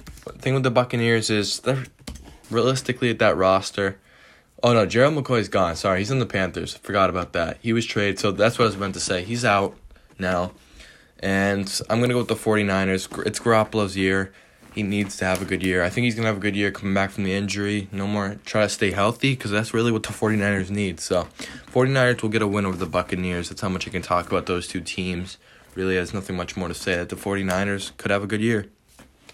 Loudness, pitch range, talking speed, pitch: -23 LUFS, 95-110 Hz, 235 wpm, 100 Hz